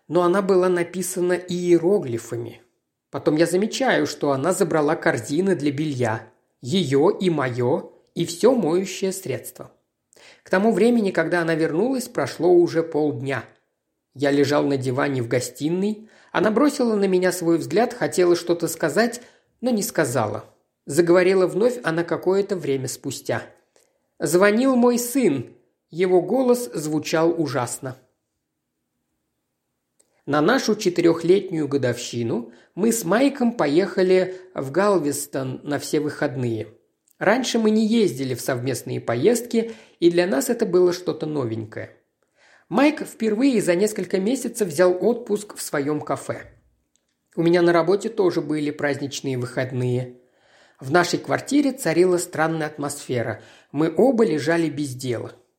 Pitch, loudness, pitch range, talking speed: 165 Hz, -21 LUFS, 140-195 Hz, 125 wpm